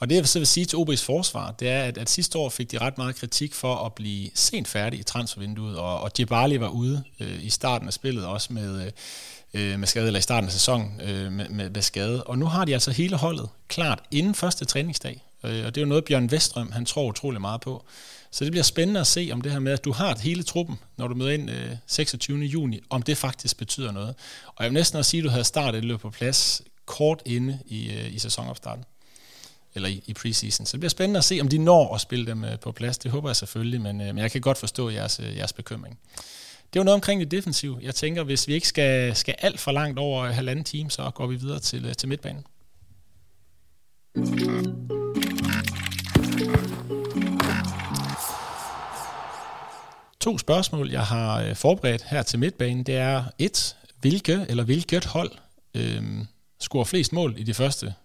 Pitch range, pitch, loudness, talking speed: 110-150 Hz, 125 Hz, -25 LUFS, 205 wpm